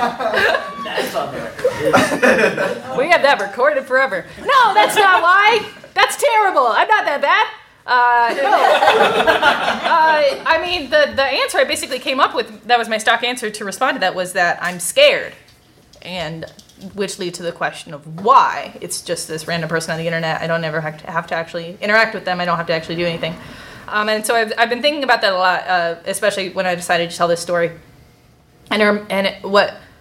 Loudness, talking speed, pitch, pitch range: -16 LUFS, 200 wpm, 200 Hz, 170-270 Hz